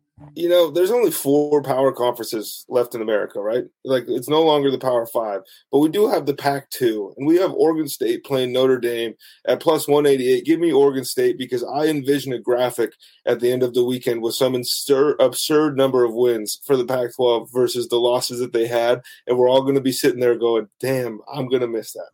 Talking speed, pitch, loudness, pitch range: 225 wpm, 135 Hz, -20 LUFS, 125-160 Hz